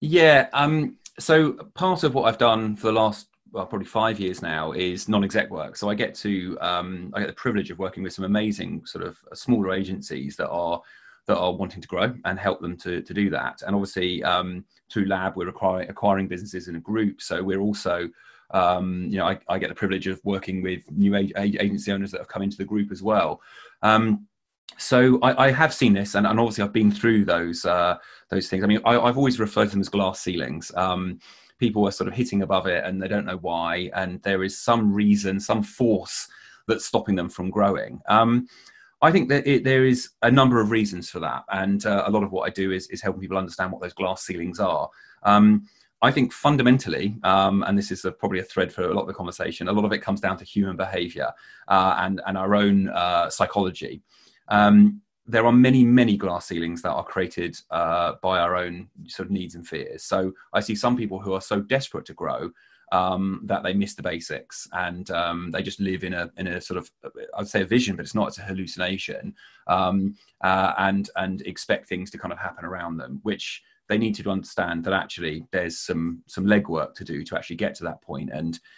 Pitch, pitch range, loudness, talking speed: 100 Hz, 90-105 Hz, -23 LUFS, 225 wpm